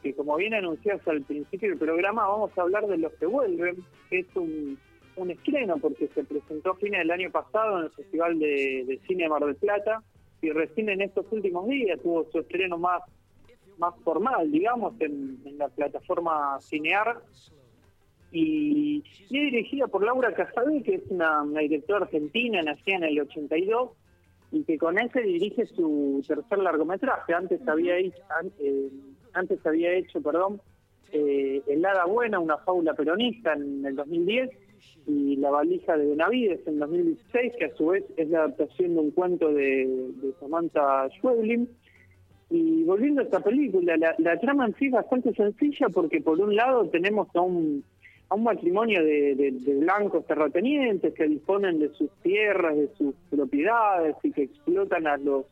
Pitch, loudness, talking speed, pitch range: 170 Hz, -26 LUFS, 170 wpm, 145-220 Hz